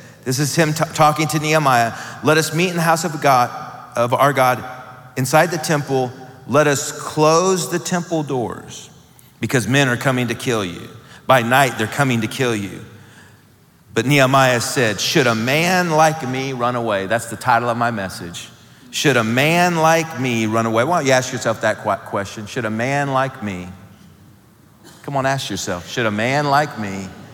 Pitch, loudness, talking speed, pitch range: 130 Hz, -18 LUFS, 185 wpm, 115-150 Hz